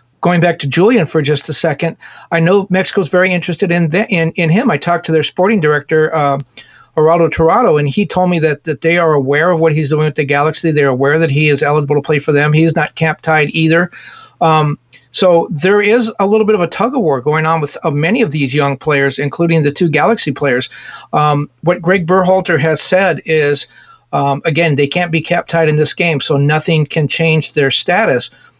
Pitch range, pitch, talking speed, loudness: 150-175 Hz, 160 Hz, 215 wpm, -12 LUFS